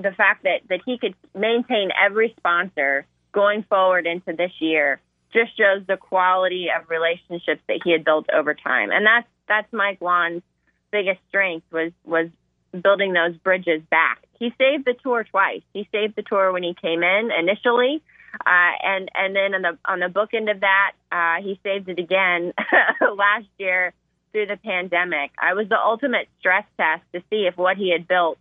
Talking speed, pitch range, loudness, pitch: 185 wpm, 175-205 Hz, -20 LUFS, 190 Hz